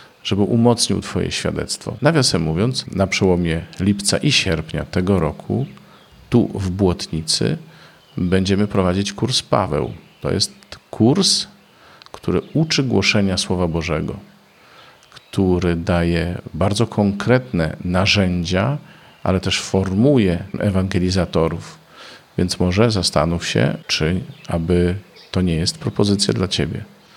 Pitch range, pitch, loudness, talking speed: 90-115 Hz, 95 Hz, -19 LUFS, 110 wpm